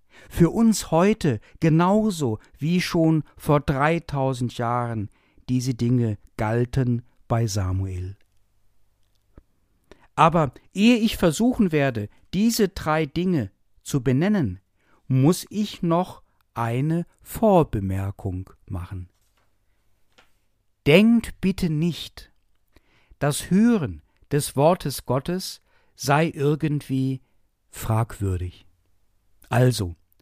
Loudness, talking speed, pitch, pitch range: -23 LUFS, 85 wpm, 125 Hz, 100-165 Hz